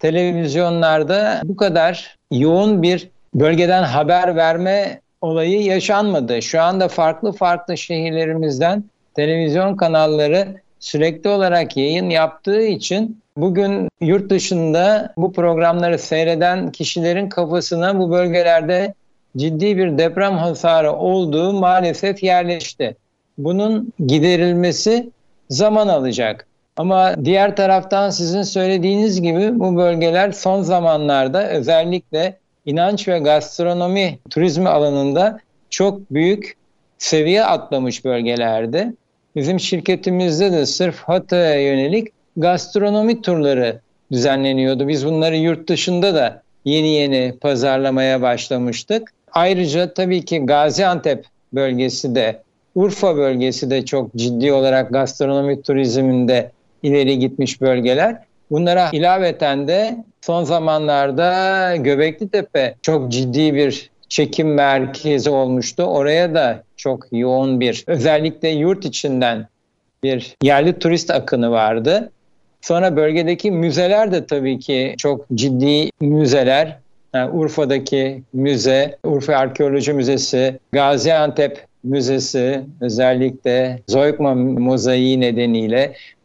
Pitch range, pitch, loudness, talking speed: 135-180 Hz, 160 Hz, -17 LUFS, 100 wpm